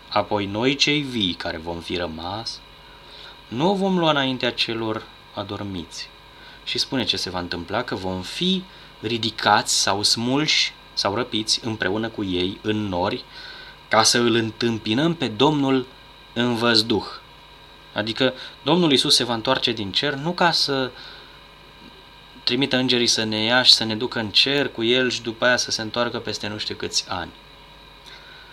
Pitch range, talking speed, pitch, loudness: 105-130 Hz, 160 wpm, 115 Hz, -21 LUFS